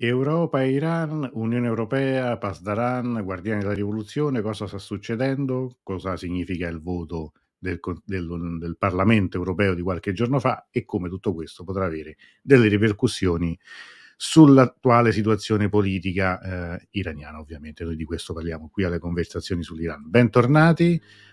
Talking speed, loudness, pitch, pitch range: 135 wpm, -23 LUFS, 100 Hz, 90-120 Hz